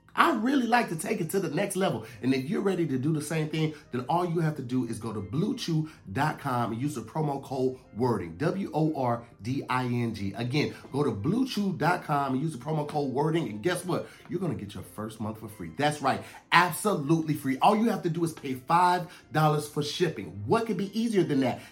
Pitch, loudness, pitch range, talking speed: 150 Hz, -28 LUFS, 125-175 Hz, 230 wpm